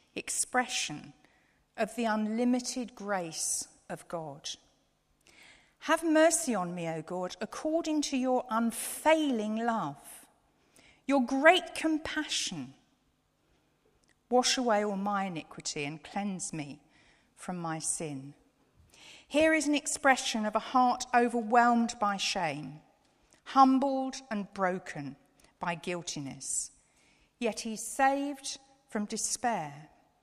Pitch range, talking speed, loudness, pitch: 185-270 Hz, 105 wpm, -30 LUFS, 230 Hz